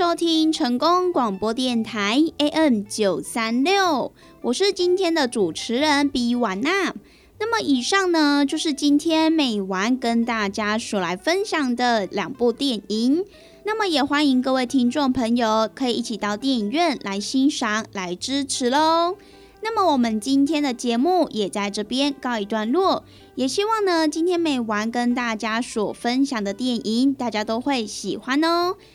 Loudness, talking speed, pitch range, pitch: -21 LUFS, 235 characters per minute, 225-315 Hz, 260 Hz